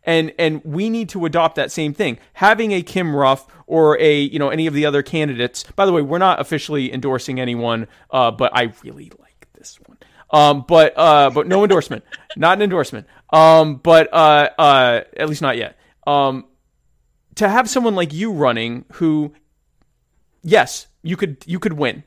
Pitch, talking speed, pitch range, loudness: 155 Hz, 185 wpm, 140-175 Hz, -16 LUFS